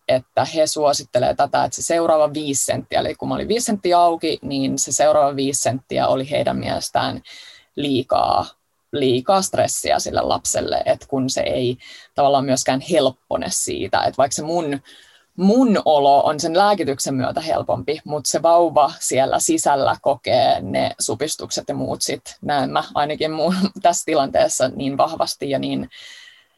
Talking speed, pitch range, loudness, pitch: 155 wpm, 140-205 Hz, -19 LUFS, 155 Hz